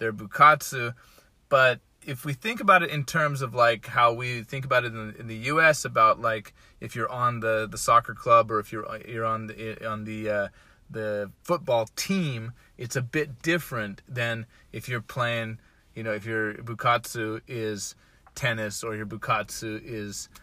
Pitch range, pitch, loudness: 110-130 Hz, 115 Hz, -26 LUFS